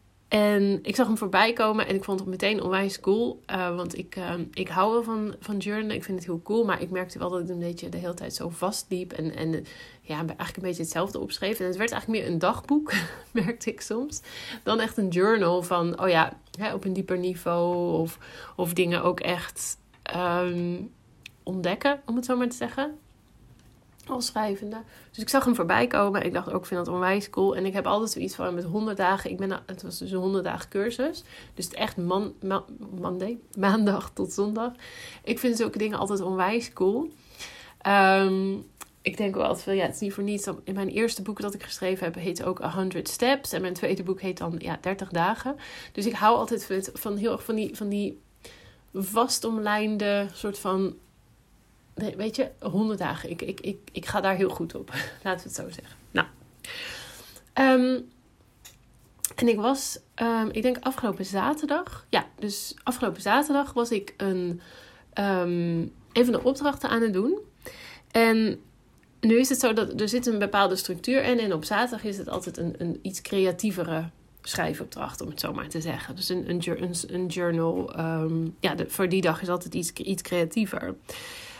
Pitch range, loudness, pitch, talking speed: 180-225 Hz, -27 LUFS, 195 Hz, 200 wpm